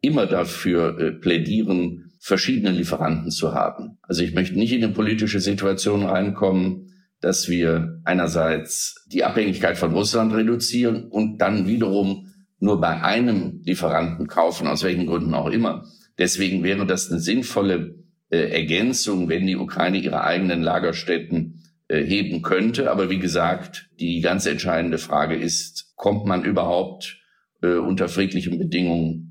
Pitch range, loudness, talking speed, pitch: 85-105 Hz, -22 LUFS, 140 wpm, 95 Hz